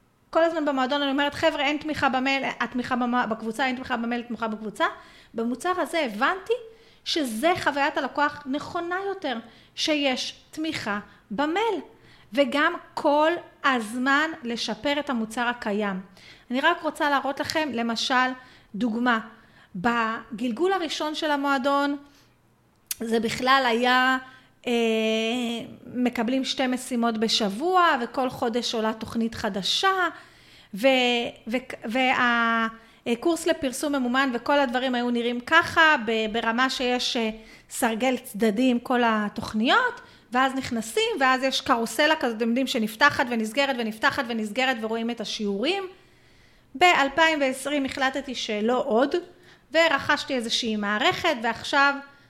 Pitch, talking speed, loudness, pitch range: 260 Hz, 115 wpm, -24 LUFS, 235-295 Hz